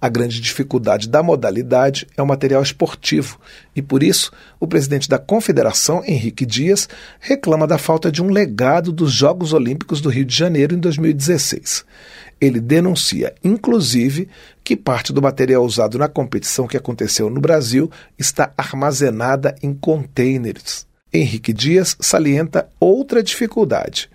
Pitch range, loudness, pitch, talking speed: 130-170 Hz, -16 LUFS, 145 Hz, 140 wpm